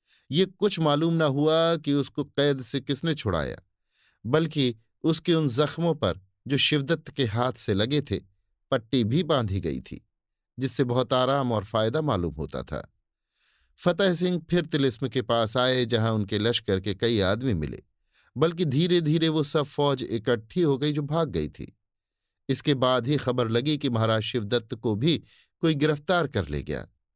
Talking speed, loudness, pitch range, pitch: 170 wpm, -26 LUFS, 110-155 Hz, 135 Hz